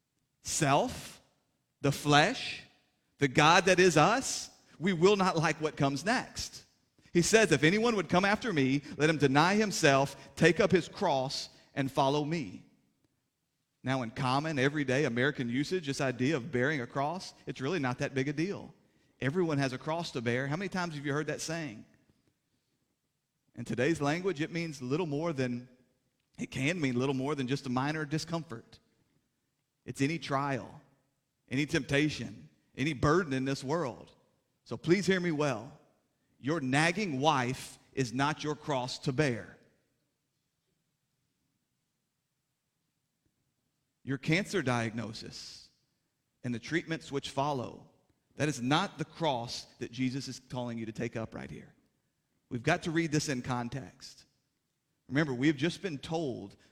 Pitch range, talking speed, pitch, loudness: 130-160 Hz, 155 wpm, 140 Hz, -31 LUFS